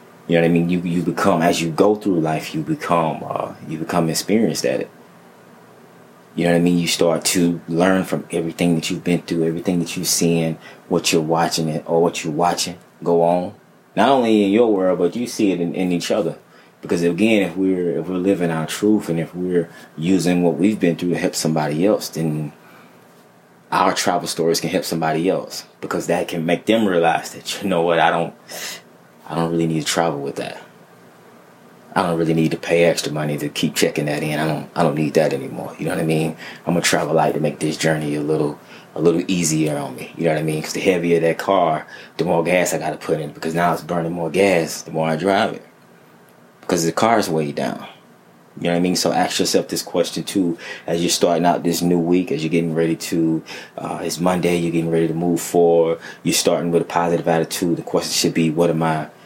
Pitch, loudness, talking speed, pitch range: 85 Hz, -19 LUFS, 235 wpm, 80-90 Hz